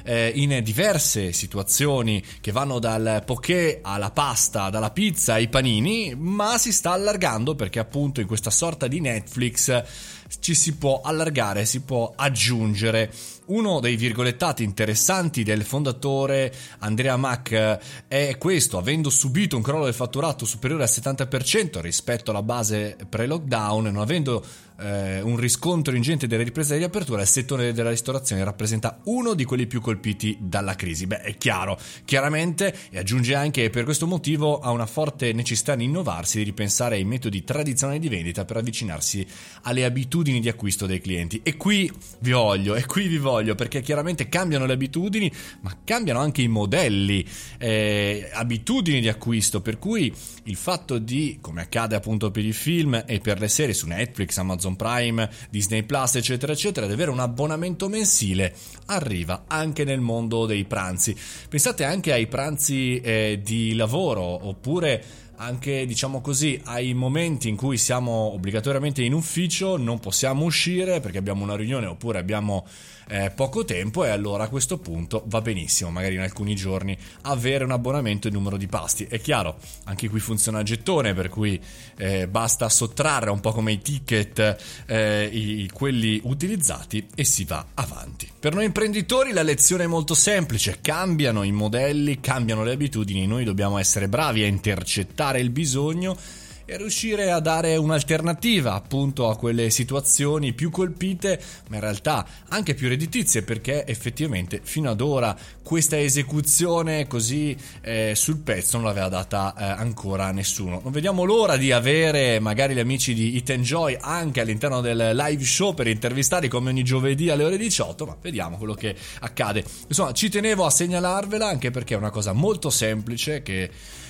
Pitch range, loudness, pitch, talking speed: 105-150 Hz, -23 LUFS, 120 Hz, 160 wpm